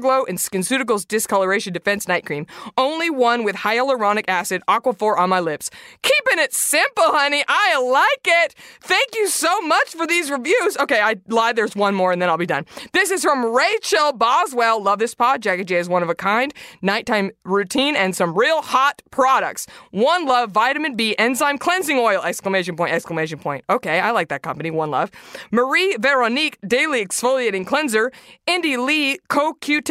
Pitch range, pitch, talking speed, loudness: 195-285 Hz, 240 Hz, 180 wpm, -18 LUFS